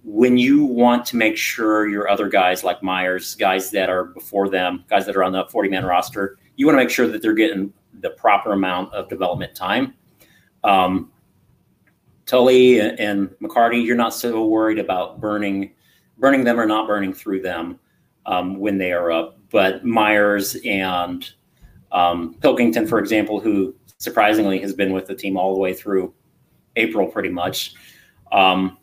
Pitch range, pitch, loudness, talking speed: 95-115 Hz, 100 Hz, -19 LUFS, 170 wpm